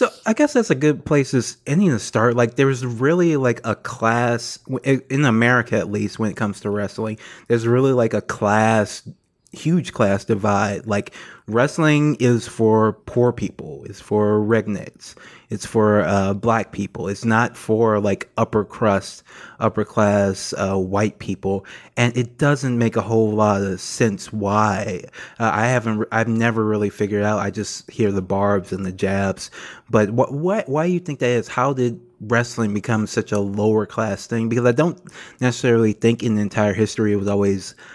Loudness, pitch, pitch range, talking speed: -20 LUFS, 110 Hz, 105-125 Hz, 180 wpm